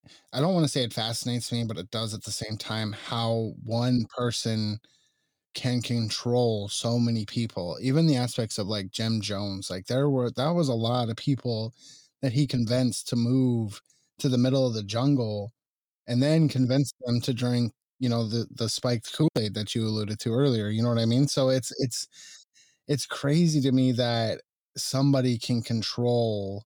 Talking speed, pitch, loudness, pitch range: 185 wpm, 120 Hz, -27 LUFS, 110-130 Hz